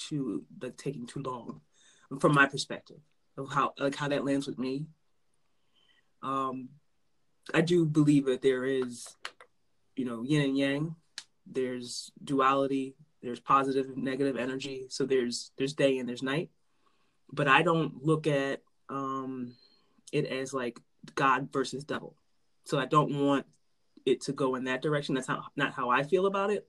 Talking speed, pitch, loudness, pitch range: 160 wpm, 135 Hz, -30 LUFS, 130-150 Hz